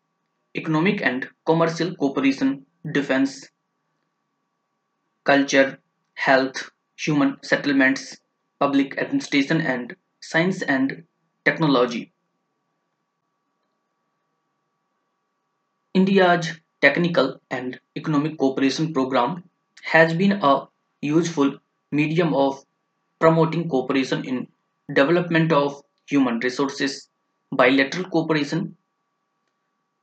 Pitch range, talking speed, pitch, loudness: 140-180 Hz, 70 wpm, 155 Hz, -21 LUFS